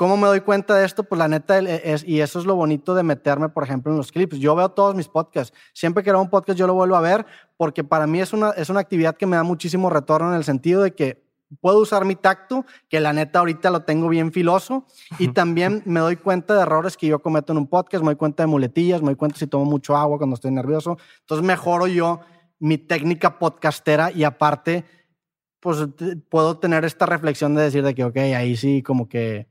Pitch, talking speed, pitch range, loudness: 165 Hz, 240 wpm, 150-185 Hz, -20 LUFS